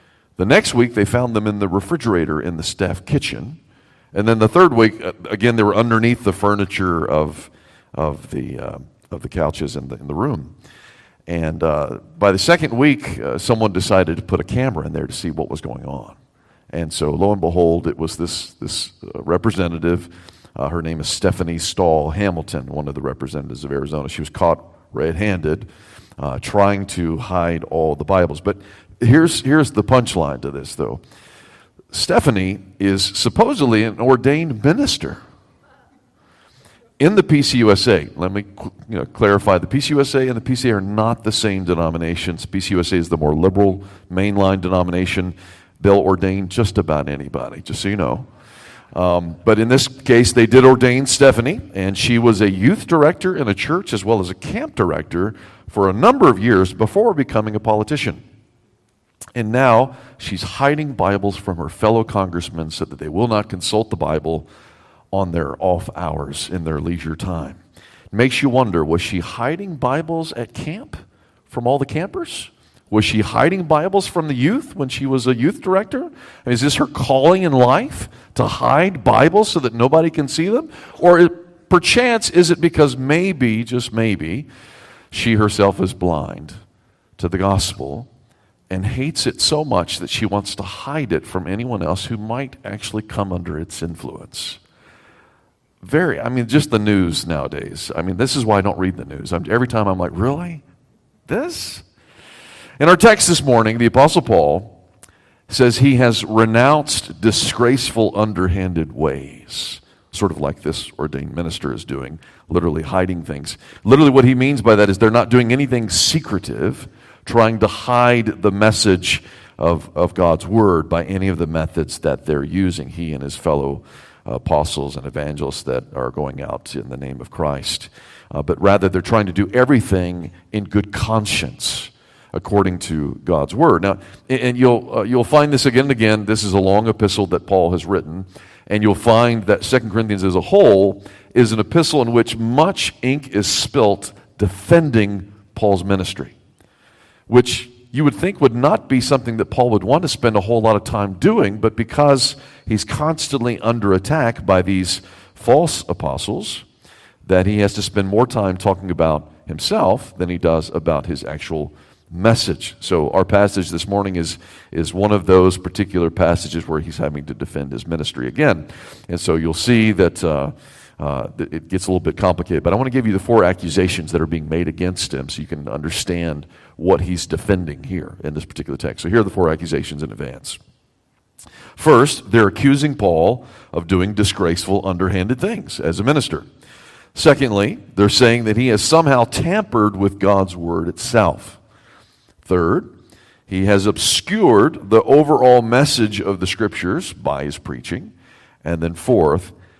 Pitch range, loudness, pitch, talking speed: 90-125 Hz, -17 LUFS, 100 Hz, 175 wpm